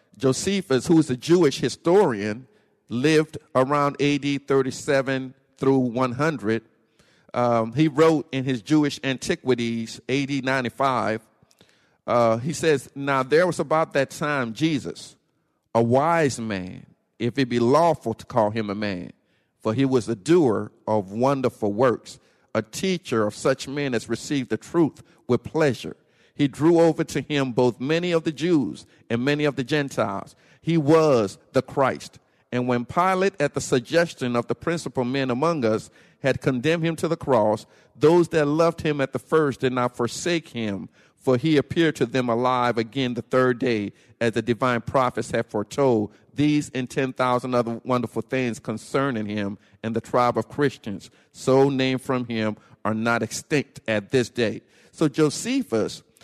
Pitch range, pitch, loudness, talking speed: 115-150 Hz, 130 Hz, -23 LUFS, 160 wpm